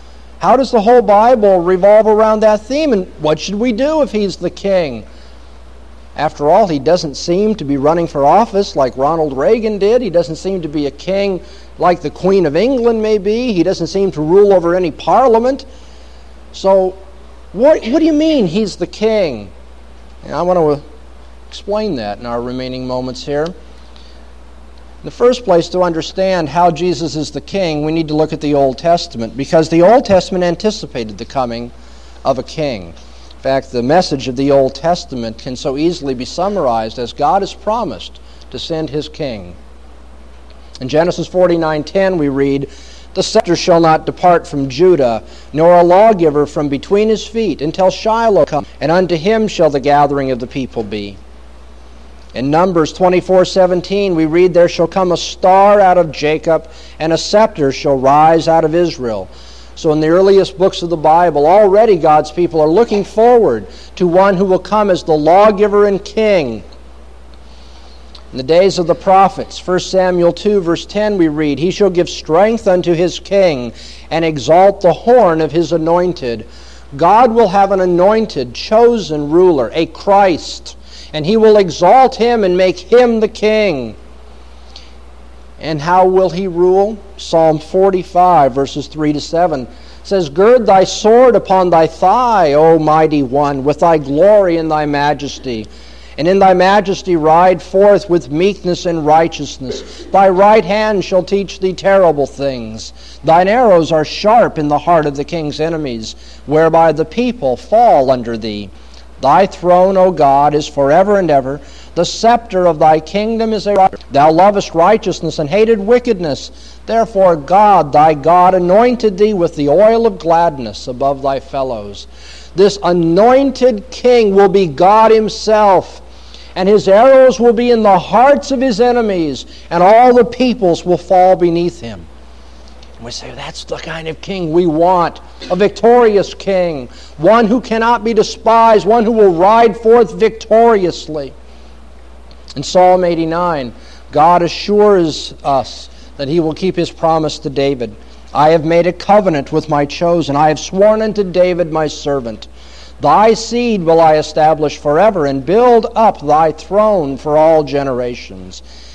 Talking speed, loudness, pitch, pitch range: 165 wpm, -12 LUFS, 170 Hz, 140-195 Hz